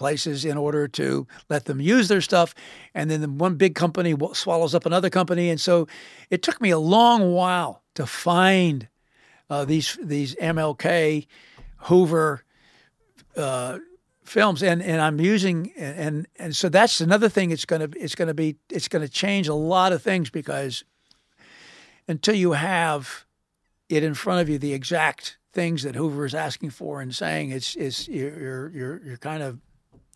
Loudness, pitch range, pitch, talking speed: -23 LUFS, 145-180 Hz, 160 Hz, 165 wpm